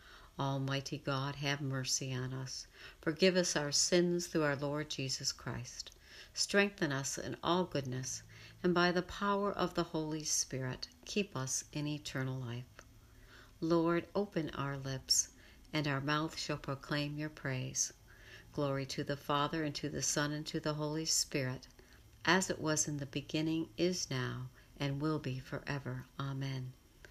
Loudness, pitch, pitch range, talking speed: -36 LUFS, 145 Hz, 130-160 Hz, 155 wpm